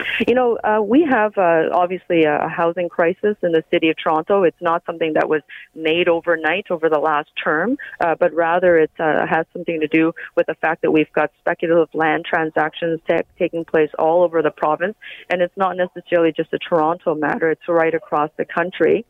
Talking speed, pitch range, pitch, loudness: 200 wpm, 160-180 Hz, 170 Hz, -18 LUFS